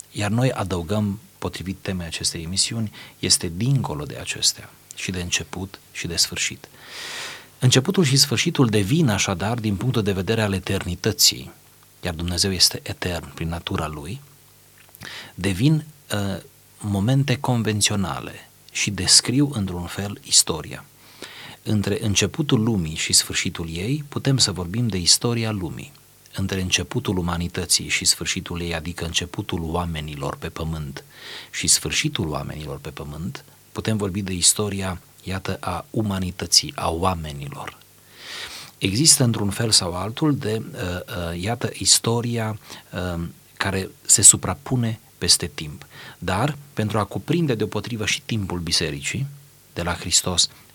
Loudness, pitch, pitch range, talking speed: -21 LUFS, 100 Hz, 90-120 Hz, 125 wpm